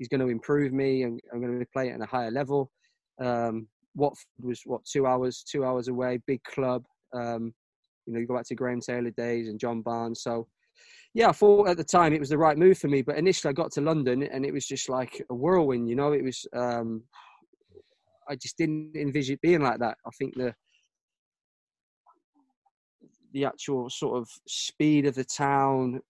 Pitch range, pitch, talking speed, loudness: 125-150 Hz, 135 Hz, 205 wpm, -27 LUFS